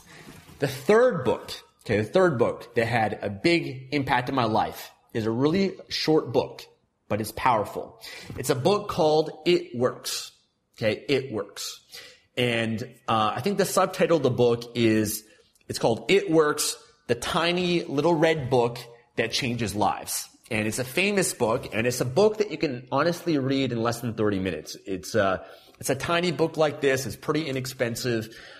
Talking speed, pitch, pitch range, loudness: 175 wpm, 145 Hz, 120-175 Hz, -25 LUFS